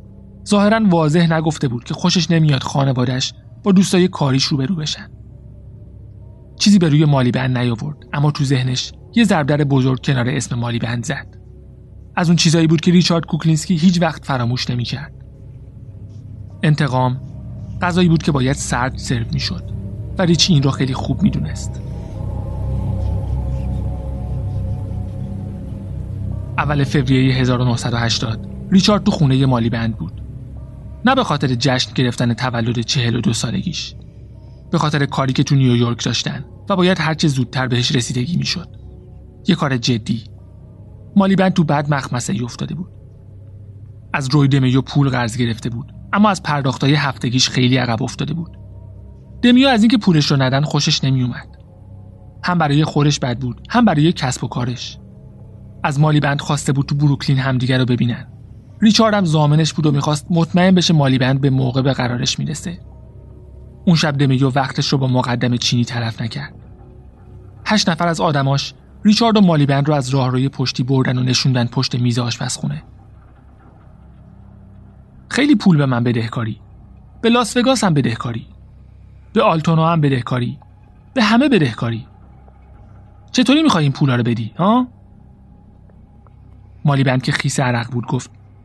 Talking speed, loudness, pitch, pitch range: 150 wpm, -17 LUFS, 130 Hz, 115-150 Hz